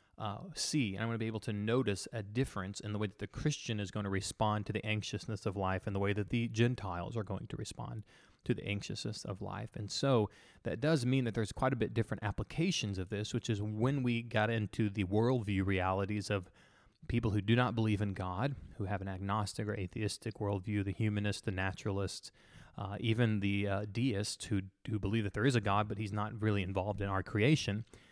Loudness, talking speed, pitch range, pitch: -36 LUFS, 225 wpm, 100-115 Hz, 105 Hz